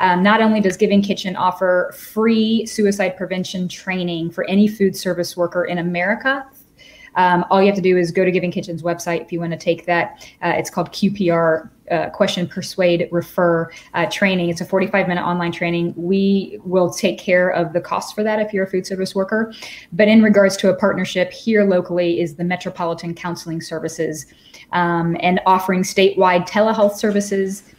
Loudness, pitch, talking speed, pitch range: -18 LUFS, 185 Hz, 185 wpm, 175-195 Hz